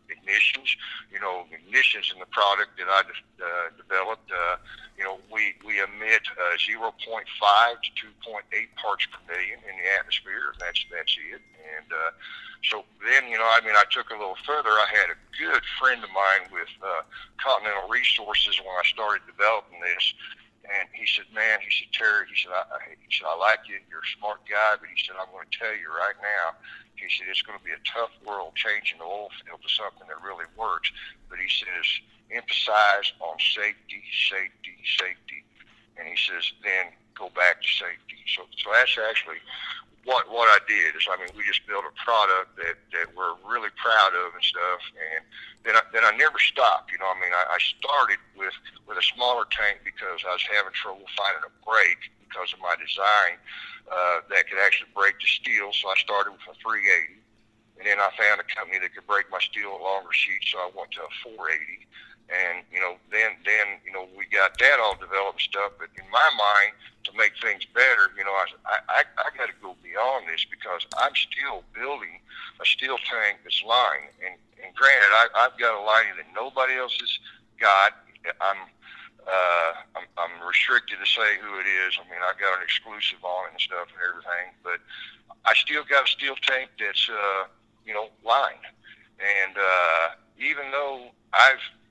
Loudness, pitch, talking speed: -23 LUFS, 125 Hz, 200 wpm